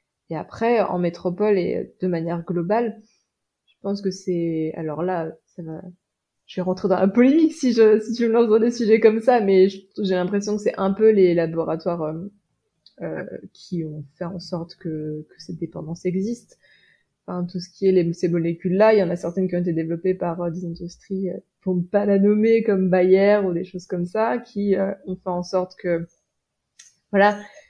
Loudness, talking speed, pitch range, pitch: -21 LUFS, 210 wpm, 175-205 Hz, 185 Hz